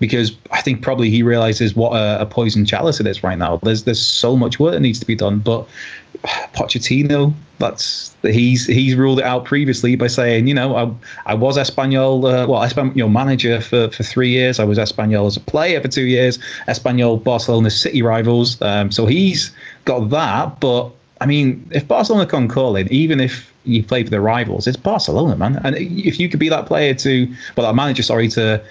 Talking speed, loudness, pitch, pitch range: 215 wpm, -16 LUFS, 125 Hz, 115-135 Hz